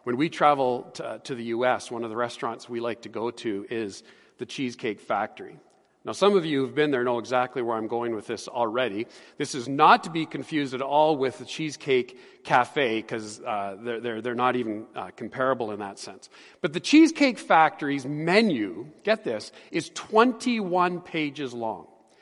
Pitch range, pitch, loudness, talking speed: 120-180 Hz, 135 Hz, -26 LUFS, 185 wpm